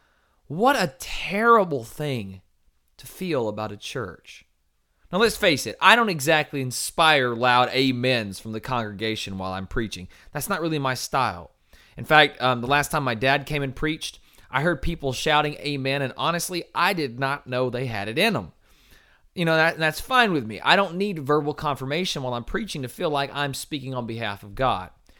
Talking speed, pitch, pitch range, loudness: 195 wpm, 140 Hz, 125-155 Hz, -23 LUFS